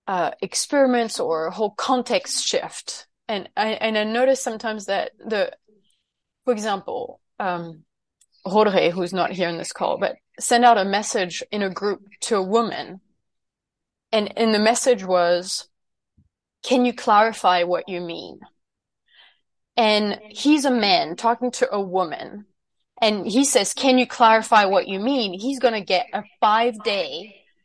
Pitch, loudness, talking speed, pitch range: 215 Hz, -21 LUFS, 150 wpm, 190-245 Hz